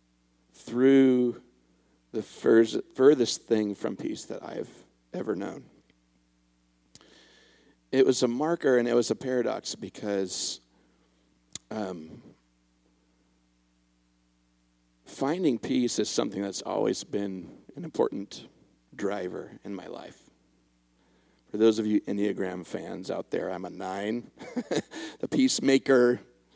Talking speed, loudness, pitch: 110 wpm, -28 LUFS, 90 Hz